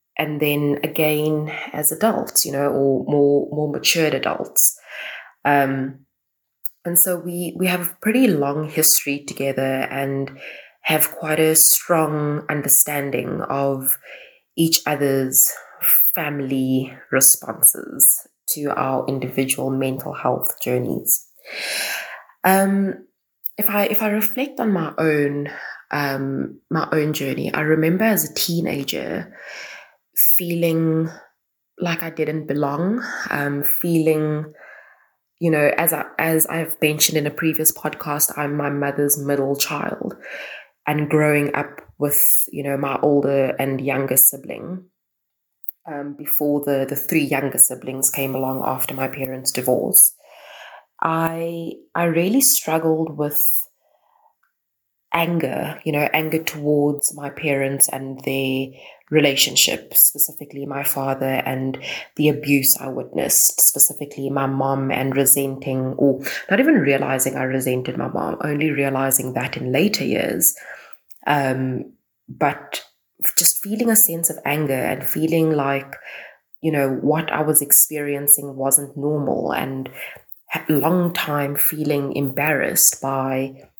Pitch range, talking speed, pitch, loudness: 135-160 Hz, 125 wpm, 145 Hz, -18 LUFS